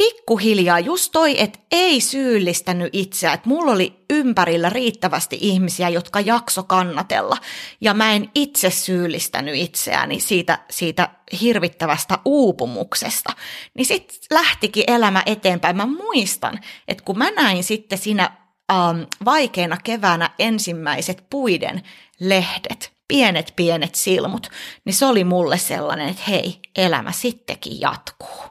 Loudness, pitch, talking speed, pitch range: -19 LUFS, 190 Hz, 125 wpm, 180-240 Hz